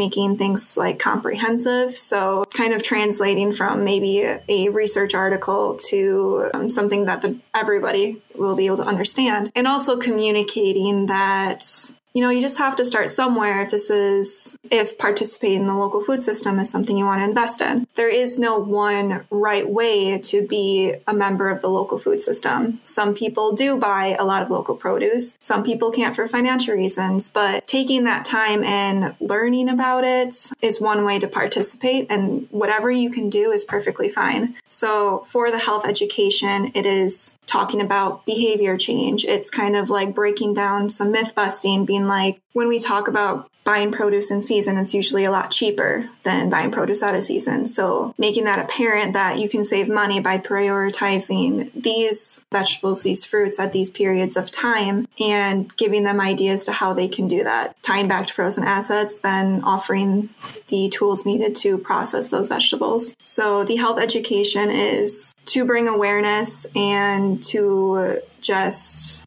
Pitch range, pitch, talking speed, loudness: 195-235 Hz, 210 Hz, 175 wpm, -19 LUFS